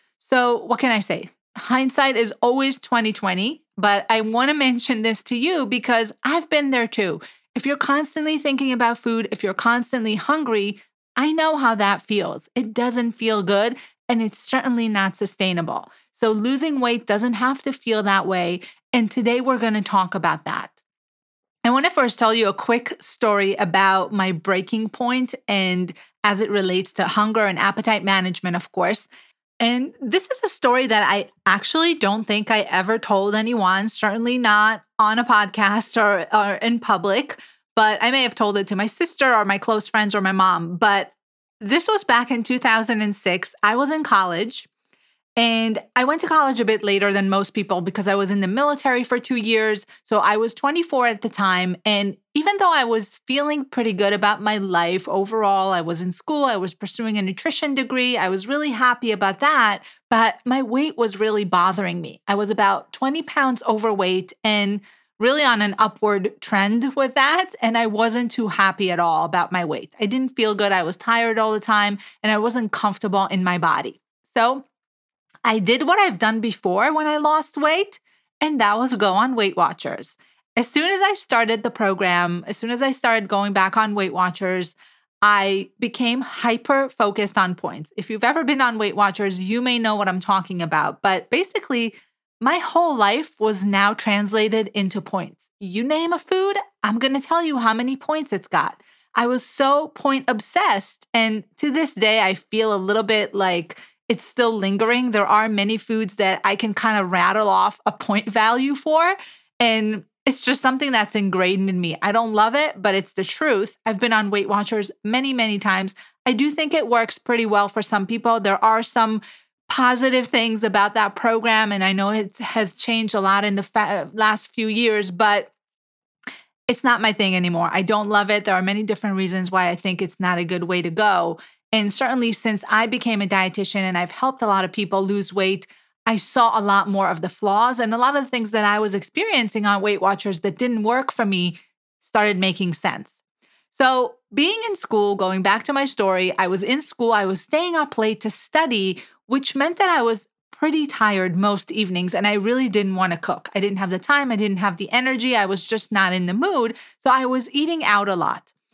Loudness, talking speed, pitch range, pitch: -20 LUFS, 205 wpm, 200-250 Hz, 220 Hz